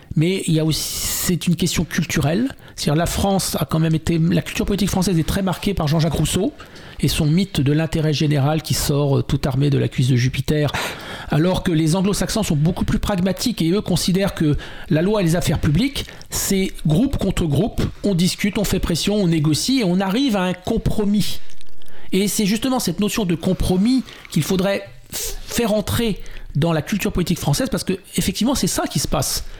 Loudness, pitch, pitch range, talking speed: -20 LUFS, 180 Hz, 155-200 Hz, 205 wpm